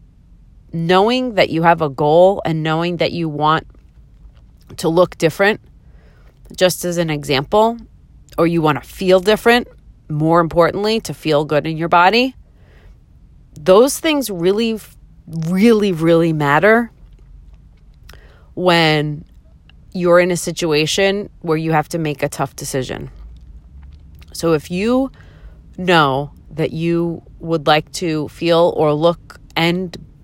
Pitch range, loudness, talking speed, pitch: 150-185 Hz, -16 LUFS, 125 wpm, 165 Hz